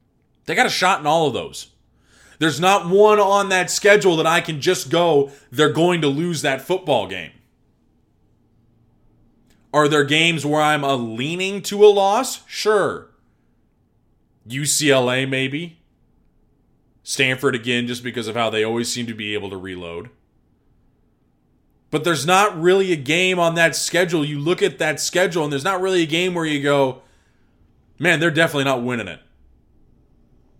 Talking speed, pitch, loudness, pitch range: 160 wpm, 150 Hz, -18 LUFS, 130-180 Hz